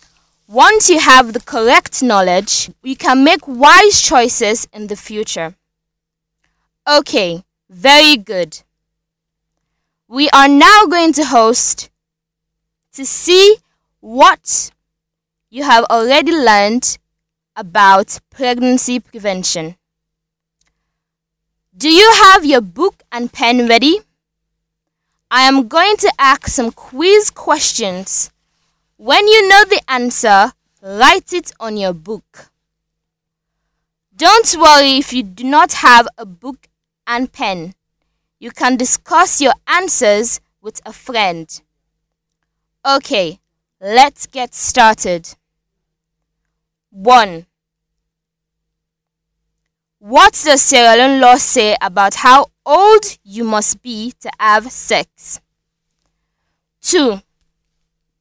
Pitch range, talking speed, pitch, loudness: 160-270 Hz, 100 wpm, 215 Hz, -10 LUFS